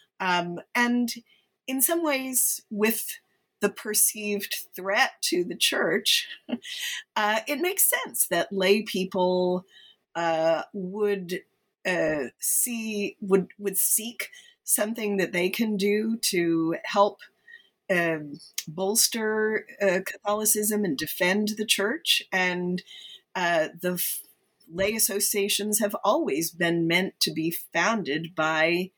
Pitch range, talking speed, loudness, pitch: 180-230 Hz, 115 wpm, -25 LUFS, 205 Hz